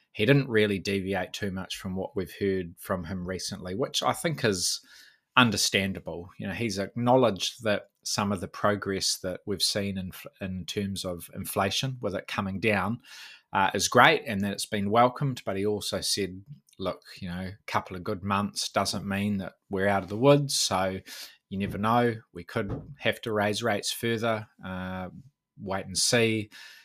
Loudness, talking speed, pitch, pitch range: -28 LUFS, 185 wpm, 100 Hz, 95-110 Hz